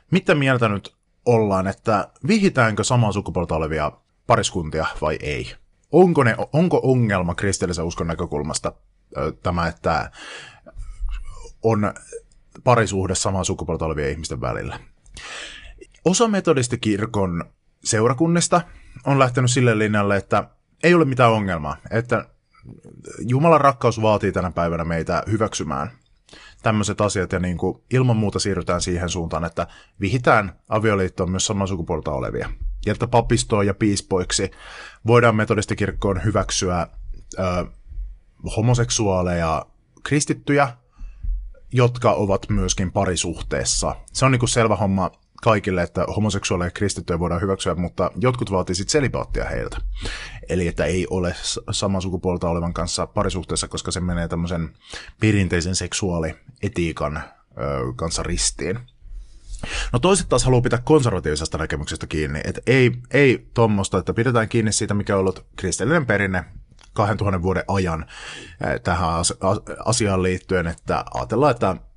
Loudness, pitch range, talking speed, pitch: -21 LUFS, 90-115 Hz, 120 wpm, 100 Hz